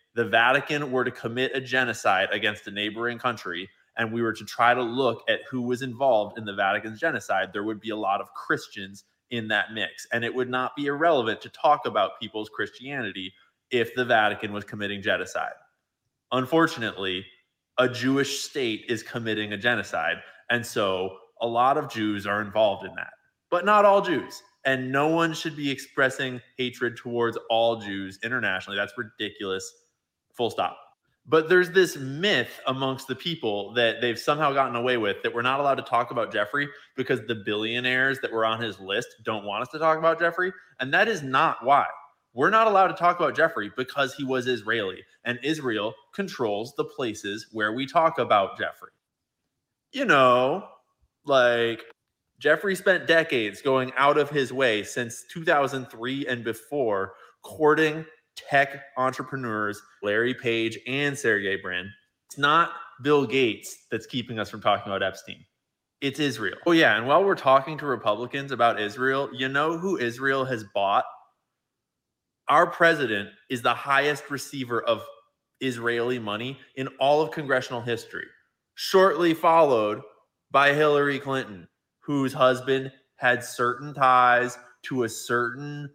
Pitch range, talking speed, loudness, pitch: 115-145 Hz, 160 wpm, -25 LUFS, 130 Hz